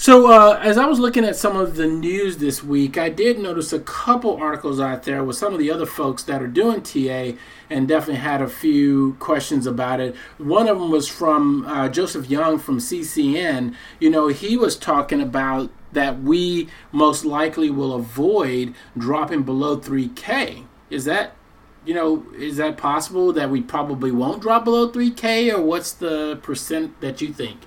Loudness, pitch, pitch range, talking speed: -19 LUFS, 155 Hz, 140-205 Hz, 185 wpm